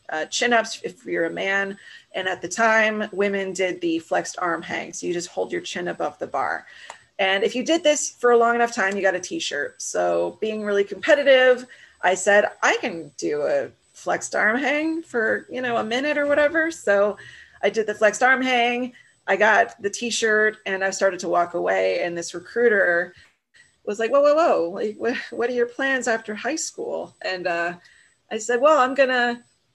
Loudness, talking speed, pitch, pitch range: -22 LUFS, 200 wpm, 220 Hz, 195-255 Hz